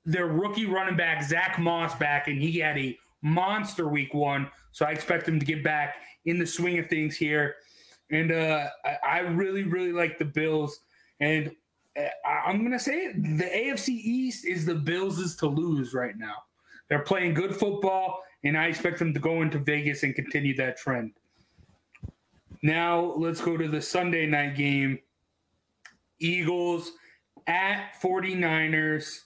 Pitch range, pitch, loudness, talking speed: 150-175 Hz, 165 Hz, -27 LUFS, 165 wpm